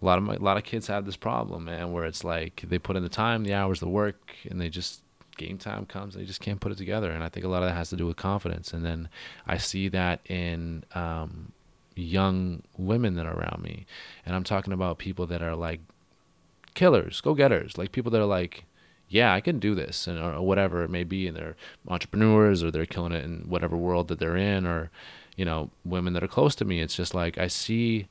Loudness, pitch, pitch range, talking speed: -28 LUFS, 90 Hz, 85-100 Hz, 250 wpm